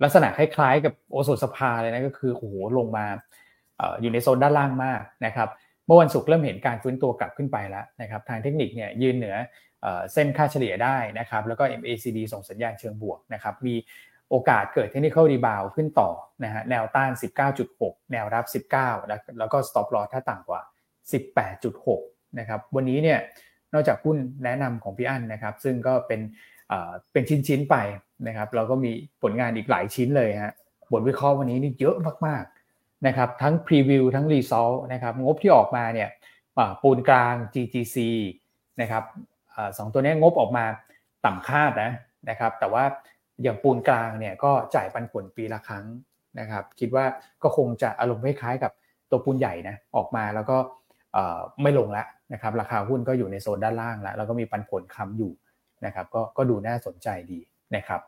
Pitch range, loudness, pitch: 110-135 Hz, -25 LUFS, 125 Hz